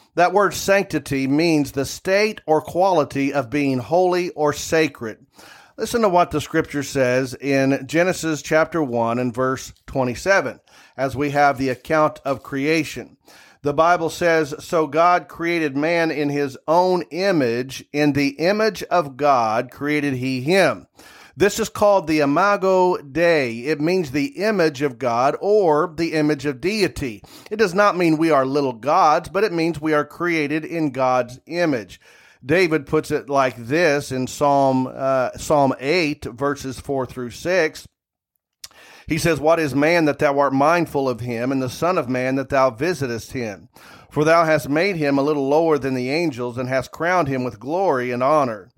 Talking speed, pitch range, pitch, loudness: 170 wpm, 135-165 Hz, 150 Hz, -20 LUFS